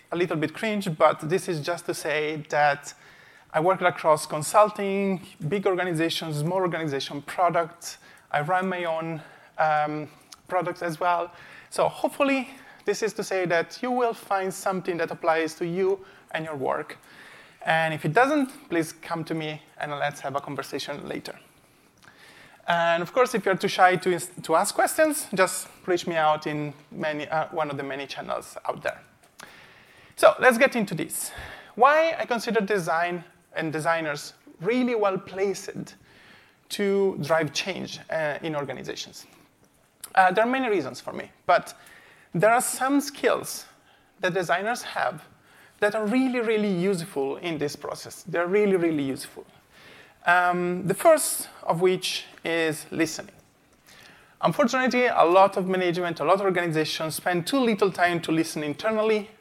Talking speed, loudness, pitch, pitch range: 155 wpm, -25 LUFS, 180 Hz, 160-205 Hz